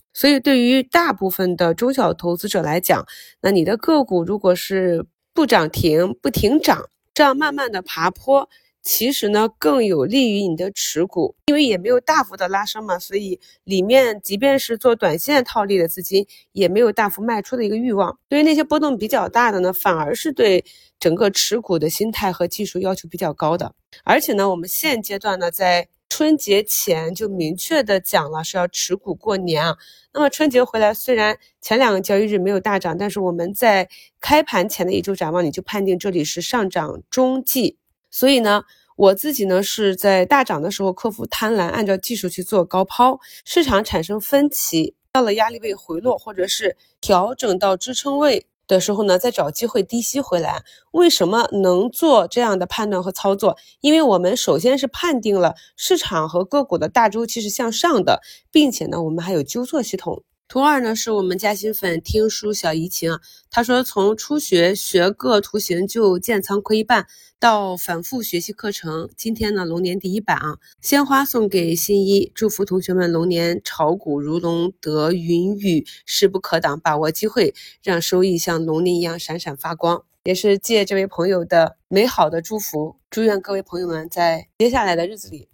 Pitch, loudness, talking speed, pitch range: 200 Hz, -19 LUFS, 285 characters per minute, 180-240 Hz